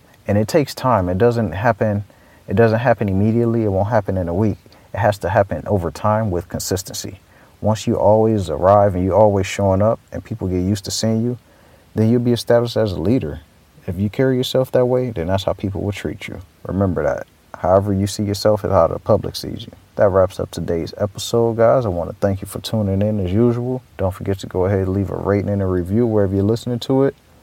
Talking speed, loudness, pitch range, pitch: 230 wpm, -18 LUFS, 95-115 Hz, 105 Hz